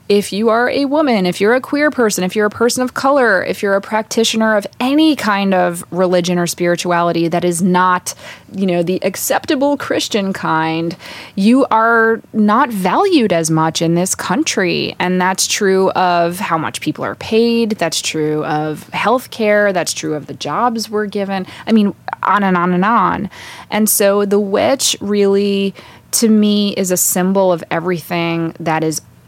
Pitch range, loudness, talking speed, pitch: 175-220 Hz, -15 LUFS, 180 wpm, 195 Hz